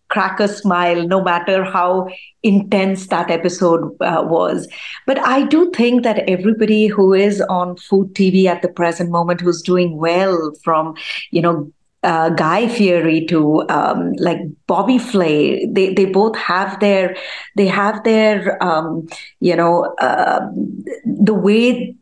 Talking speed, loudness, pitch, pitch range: 145 wpm, -15 LUFS, 185 Hz, 170-205 Hz